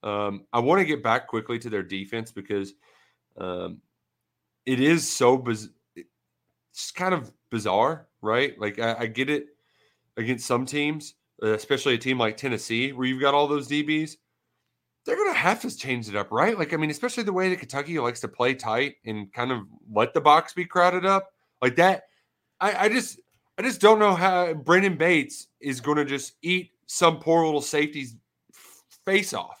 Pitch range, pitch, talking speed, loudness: 115-175 Hz, 145 Hz, 190 wpm, -24 LUFS